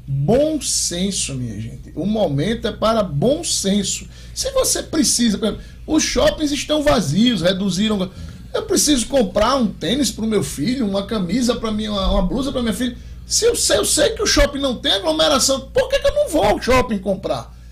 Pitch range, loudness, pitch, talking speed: 200-285 Hz, -18 LUFS, 230 Hz, 185 wpm